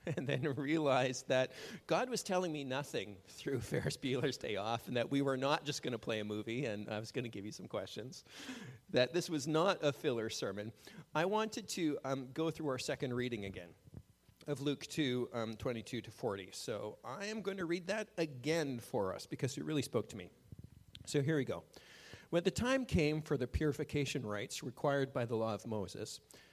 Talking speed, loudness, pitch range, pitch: 210 wpm, -38 LUFS, 115-155 Hz, 135 Hz